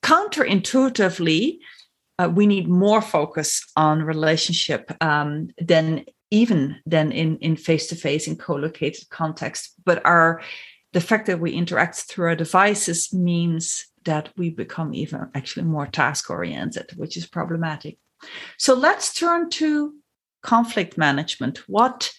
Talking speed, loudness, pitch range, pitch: 125 wpm, -21 LUFS, 160-210 Hz, 170 Hz